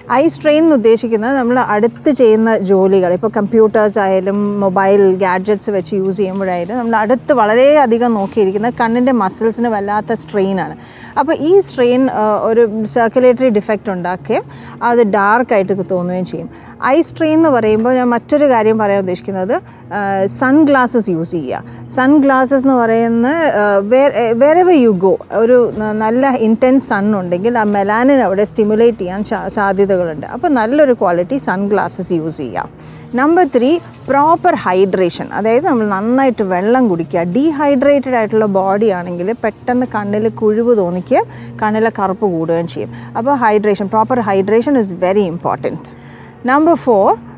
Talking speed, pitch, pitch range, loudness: 125 wpm, 220 Hz, 195-255 Hz, -13 LUFS